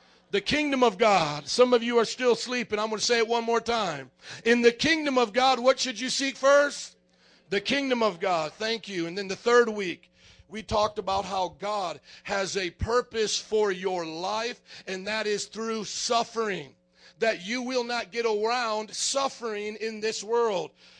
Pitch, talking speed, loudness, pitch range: 225 Hz, 185 wpm, -26 LUFS, 205-245 Hz